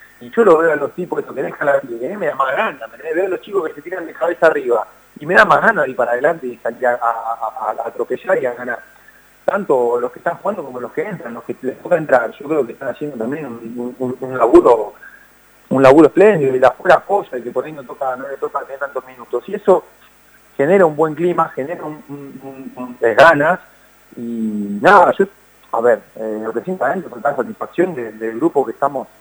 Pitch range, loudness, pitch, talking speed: 120-175 Hz, -16 LUFS, 130 Hz, 240 wpm